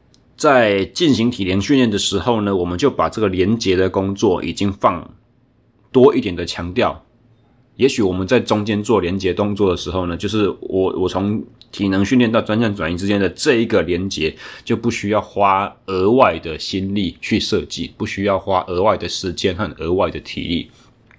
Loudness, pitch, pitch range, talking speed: -18 LUFS, 100 Hz, 95-105 Hz, 275 characters per minute